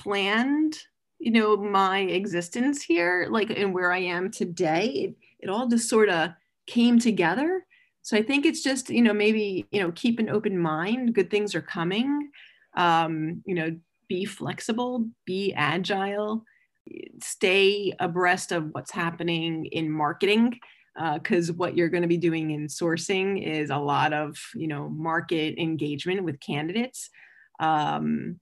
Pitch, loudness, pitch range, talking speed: 195 Hz, -25 LUFS, 170-230 Hz, 155 wpm